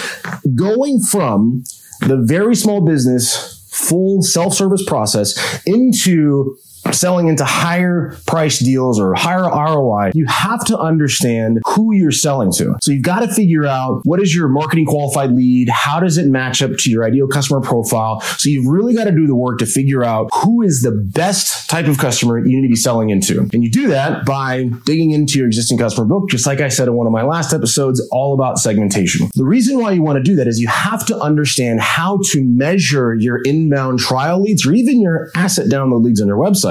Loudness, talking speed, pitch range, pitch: -14 LUFS, 205 wpm, 125-180 Hz, 140 Hz